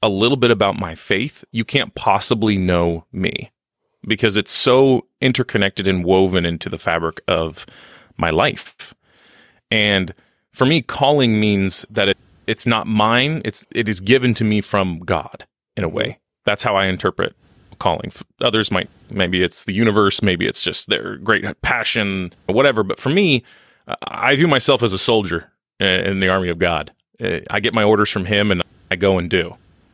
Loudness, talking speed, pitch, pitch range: -18 LUFS, 175 wpm, 100 Hz, 95-115 Hz